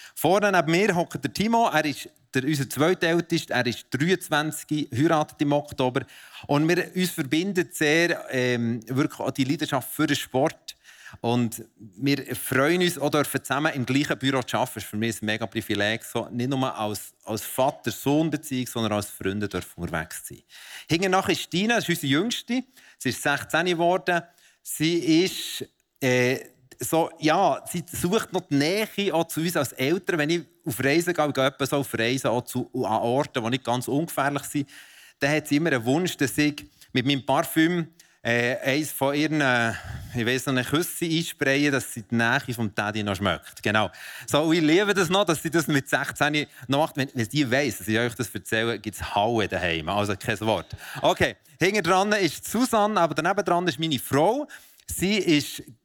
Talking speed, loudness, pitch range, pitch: 175 wpm, -25 LUFS, 120-165 Hz, 140 Hz